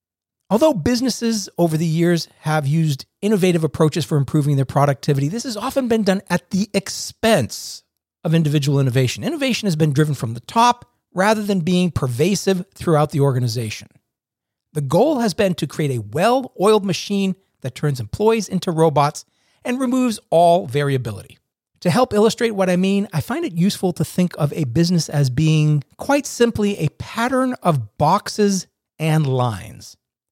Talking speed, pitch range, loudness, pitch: 160 wpm, 145-205 Hz, -19 LUFS, 170 Hz